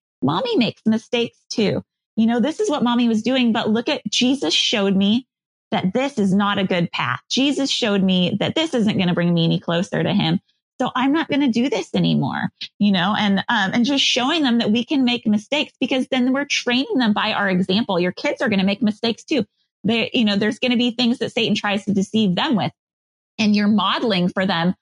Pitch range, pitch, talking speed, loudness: 200-250 Hz, 225 Hz, 230 wpm, -19 LUFS